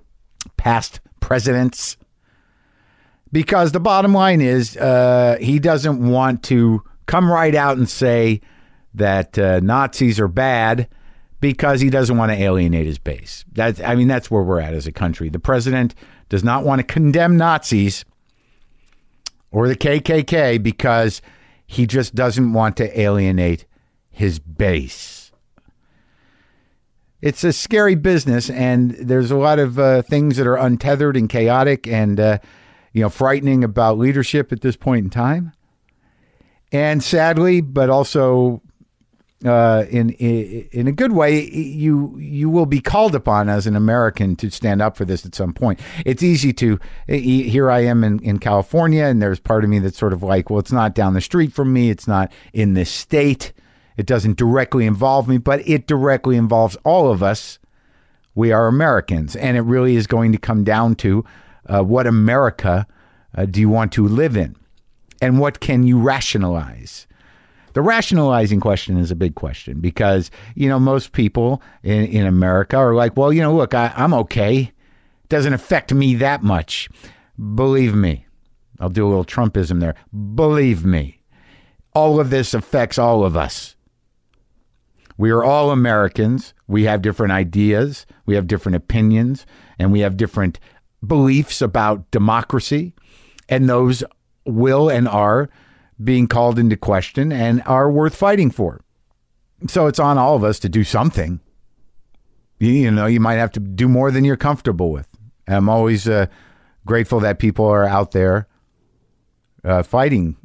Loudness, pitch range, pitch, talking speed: -17 LUFS, 100-135 Hz, 120 Hz, 160 wpm